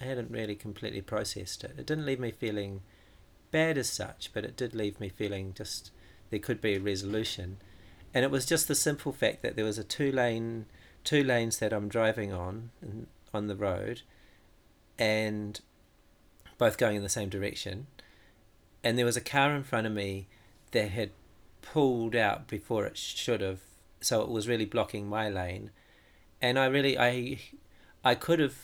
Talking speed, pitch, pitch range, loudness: 180 wpm, 105 Hz, 100-120 Hz, -31 LUFS